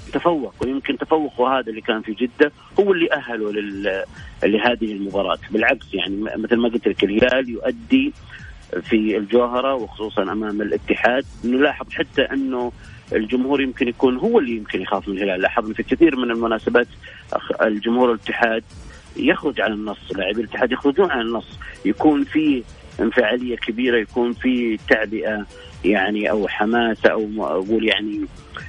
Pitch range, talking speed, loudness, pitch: 110-130 Hz, 140 wpm, -20 LUFS, 120 Hz